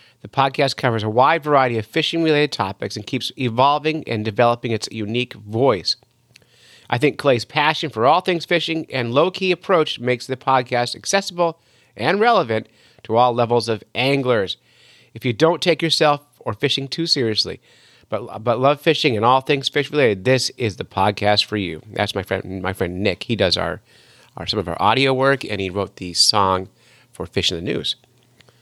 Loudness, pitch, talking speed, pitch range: -19 LUFS, 125 Hz, 185 wpm, 110-150 Hz